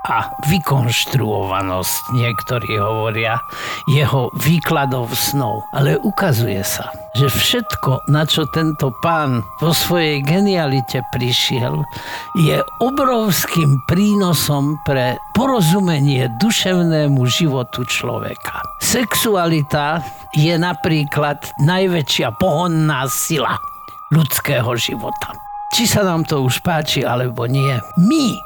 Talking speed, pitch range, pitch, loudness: 95 wpm, 125-170 Hz, 145 Hz, -17 LUFS